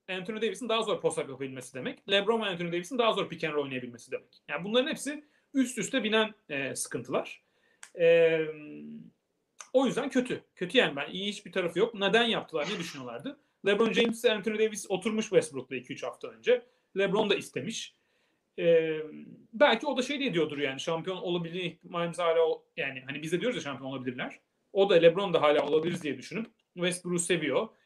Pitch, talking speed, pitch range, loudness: 190 Hz, 175 wpm, 160-230 Hz, -29 LUFS